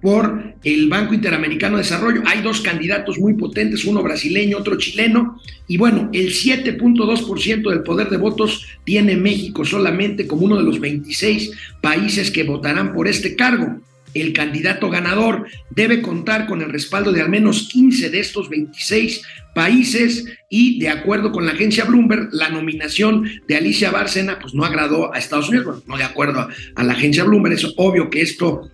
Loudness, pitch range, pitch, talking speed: -17 LUFS, 170-220 Hz, 205 Hz, 175 wpm